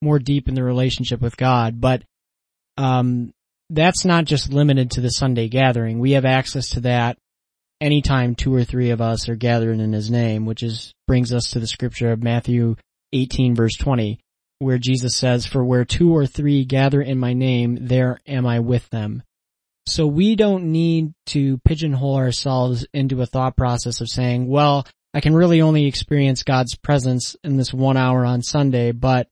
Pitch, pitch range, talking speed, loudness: 130 Hz, 120-140 Hz, 185 wpm, -19 LUFS